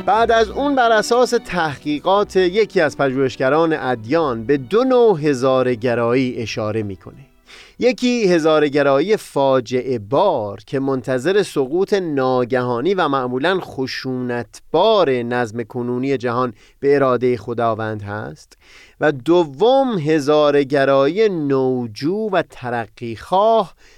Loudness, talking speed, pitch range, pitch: -18 LUFS, 105 wpm, 125-180 Hz, 135 Hz